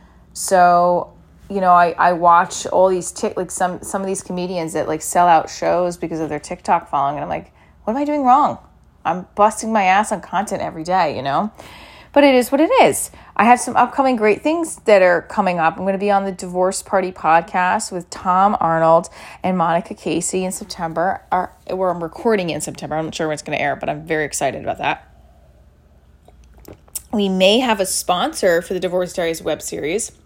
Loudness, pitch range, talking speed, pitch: -18 LUFS, 165-200 Hz, 215 wpm, 180 Hz